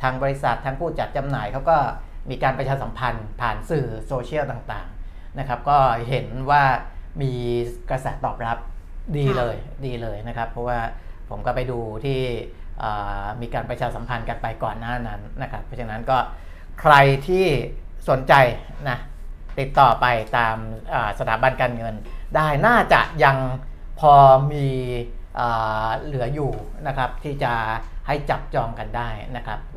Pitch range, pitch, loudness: 110-135 Hz, 120 Hz, -22 LUFS